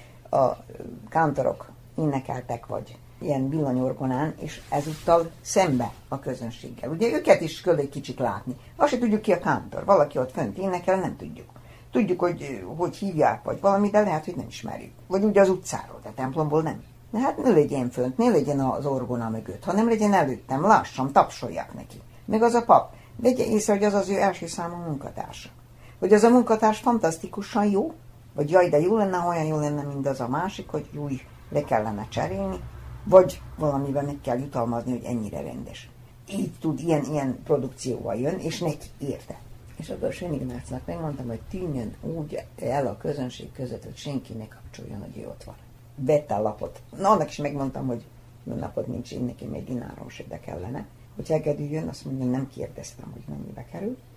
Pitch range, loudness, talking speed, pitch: 120-180 Hz, -25 LUFS, 180 wpm, 145 Hz